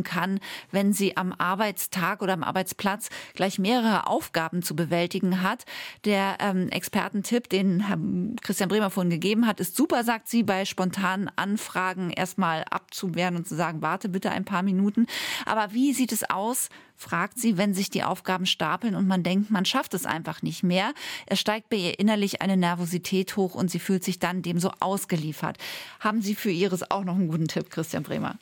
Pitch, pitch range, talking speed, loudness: 190 Hz, 180-210 Hz, 190 wpm, -26 LUFS